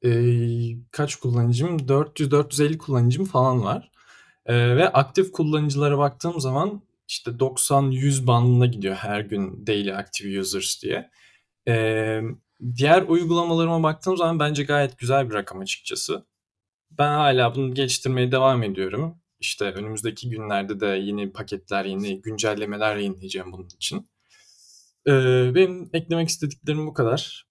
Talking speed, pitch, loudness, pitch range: 125 wpm, 125 Hz, -23 LUFS, 105-145 Hz